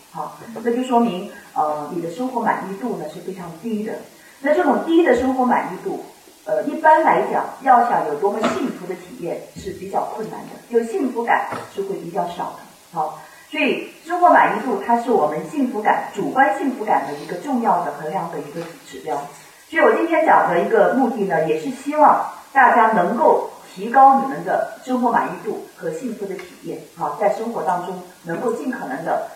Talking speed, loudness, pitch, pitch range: 290 characters per minute, -19 LUFS, 235 Hz, 190-290 Hz